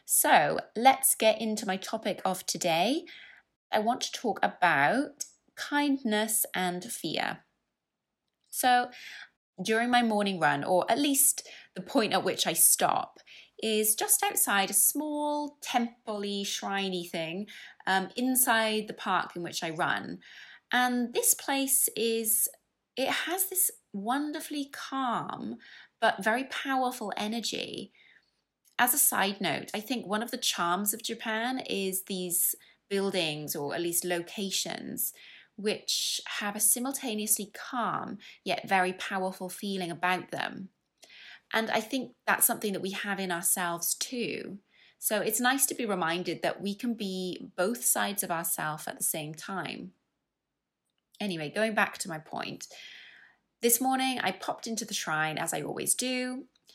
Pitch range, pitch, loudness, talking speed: 190-250 Hz, 215 Hz, -29 LUFS, 145 wpm